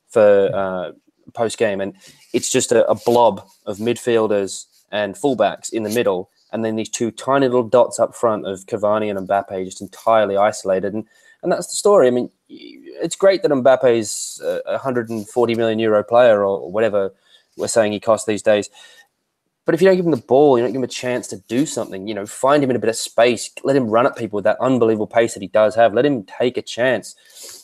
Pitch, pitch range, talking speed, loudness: 115 Hz, 105-135 Hz, 220 wpm, -18 LUFS